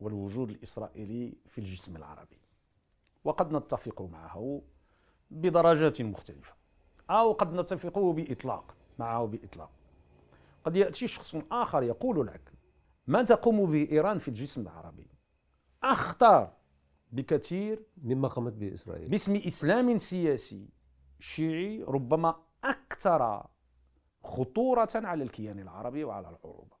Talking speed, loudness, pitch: 105 wpm, -30 LUFS, 115 Hz